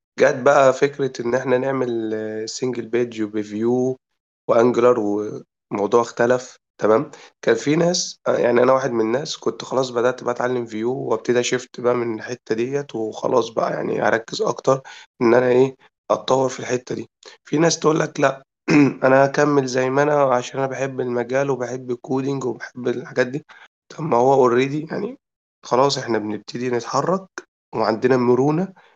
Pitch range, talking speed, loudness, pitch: 120-135 Hz, 155 wpm, -20 LUFS, 125 Hz